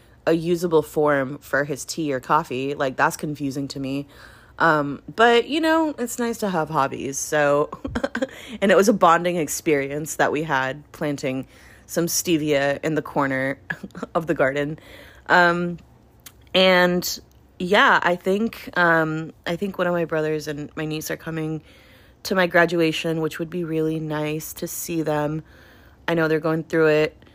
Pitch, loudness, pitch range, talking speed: 160 Hz, -22 LUFS, 145-175 Hz, 165 wpm